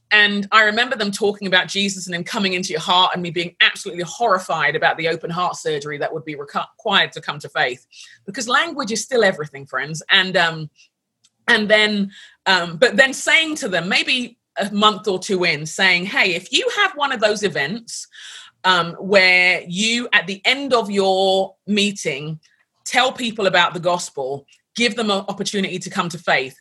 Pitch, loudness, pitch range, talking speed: 195 Hz, -18 LUFS, 175-220 Hz, 190 wpm